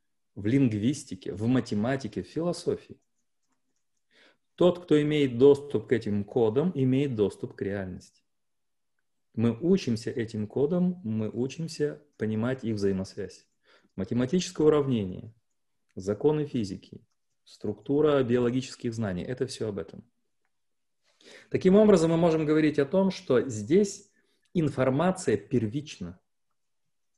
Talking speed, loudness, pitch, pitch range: 105 wpm, -27 LUFS, 130 Hz, 110-155 Hz